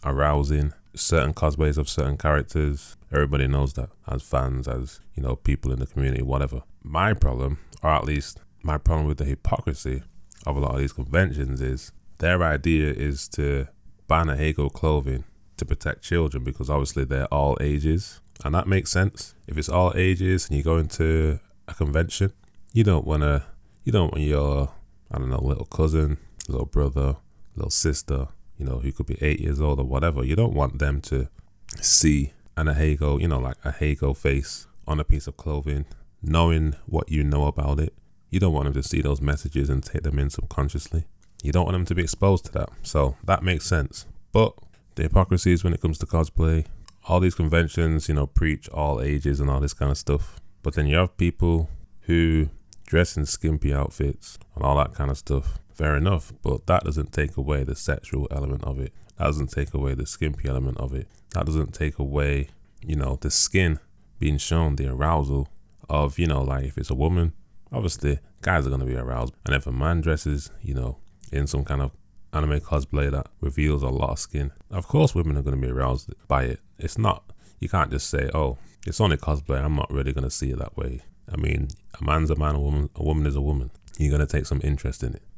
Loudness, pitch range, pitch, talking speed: -25 LUFS, 70-85 Hz, 75 Hz, 205 wpm